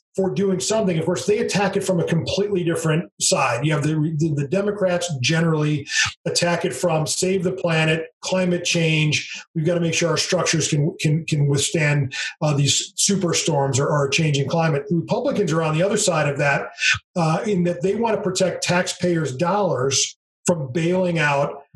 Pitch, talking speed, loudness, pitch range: 170 Hz, 190 wpm, -20 LUFS, 155-185 Hz